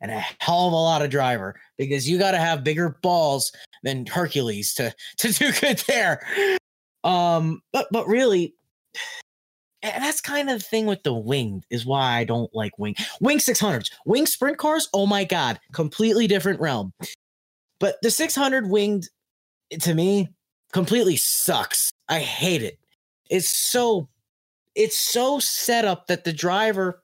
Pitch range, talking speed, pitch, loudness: 140-230 Hz, 160 wpm, 180 Hz, -22 LUFS